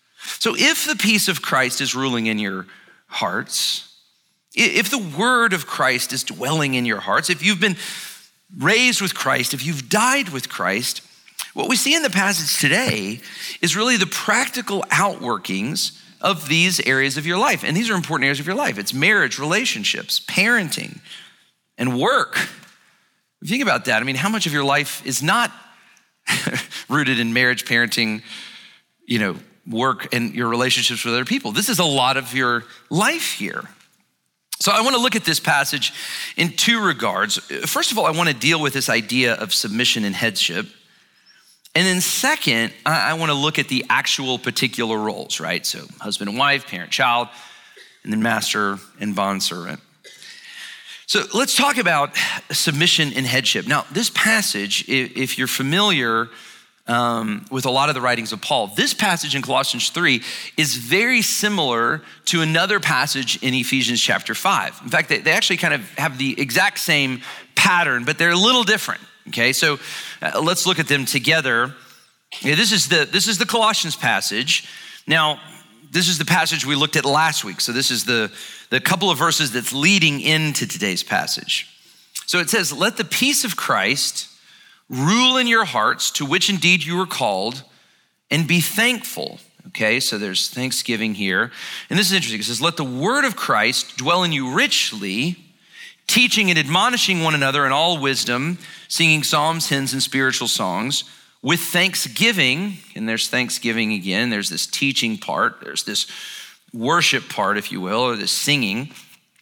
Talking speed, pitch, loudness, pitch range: 175 wpm, 155 Hz, -18 LUFS, 125-195 Hz